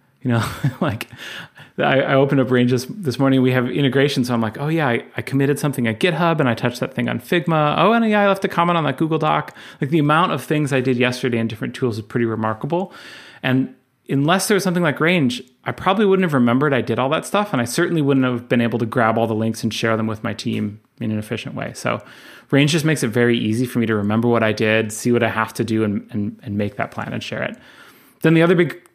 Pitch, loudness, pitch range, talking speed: 130 Hz, -19 LUFS, 115-155 Hz, 260 wpm